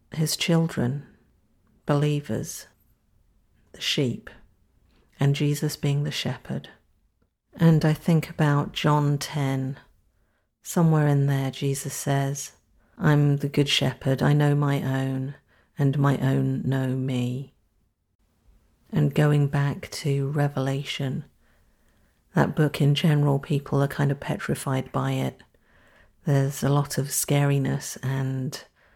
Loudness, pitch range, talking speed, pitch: -25 LUFS, 130-145 Hz, 115 wpm, 140 Hz